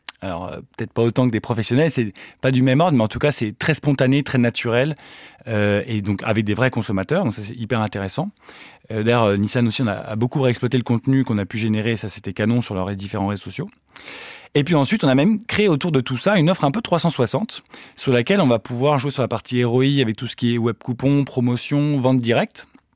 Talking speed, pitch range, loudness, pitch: 245 wpm, 110-140 Hz, -20 LUFS, 125 Hz